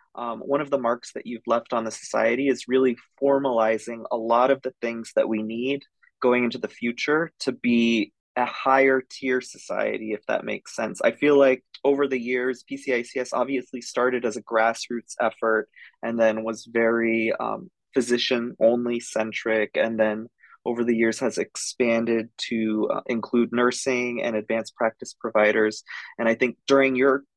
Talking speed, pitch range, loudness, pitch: 165 wpm, 115-130 Hz, -24 LUFS, 120 Hz